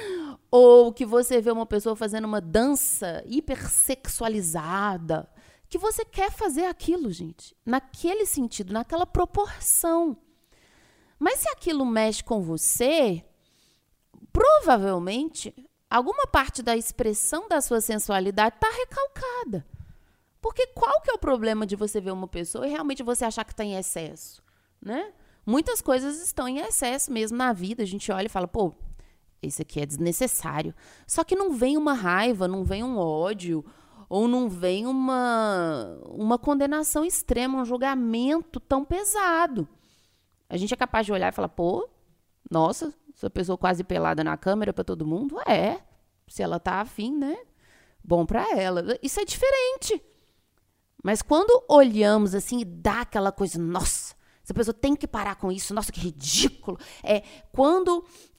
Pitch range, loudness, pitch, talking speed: 195-300 Hz, -25 LUFS, 240 Hz, 150 wpm